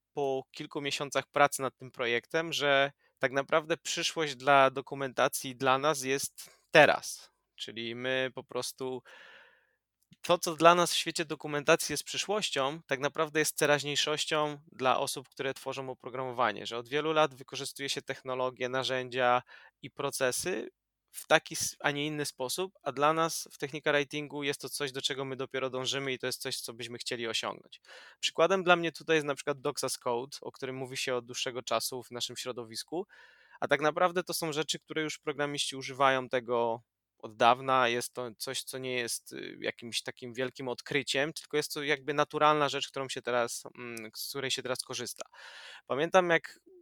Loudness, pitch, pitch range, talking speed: -31 LUFS, 135 Hz, 130-150 Hz, 175 wpm